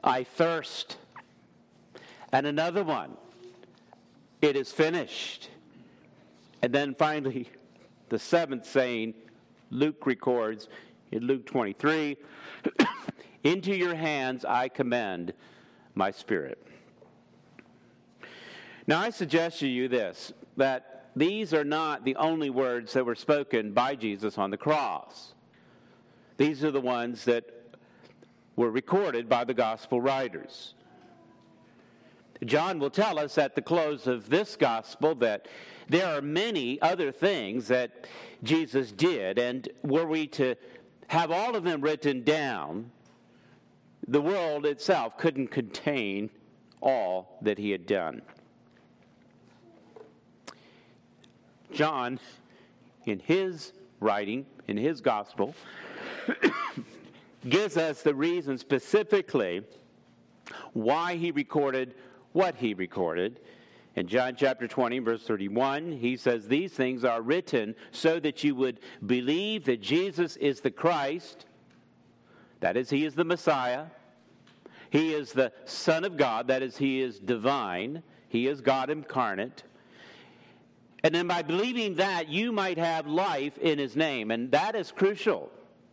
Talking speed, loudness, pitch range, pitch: 120 wpm, -29 LUFS, 125-160 Hz, 140 Hz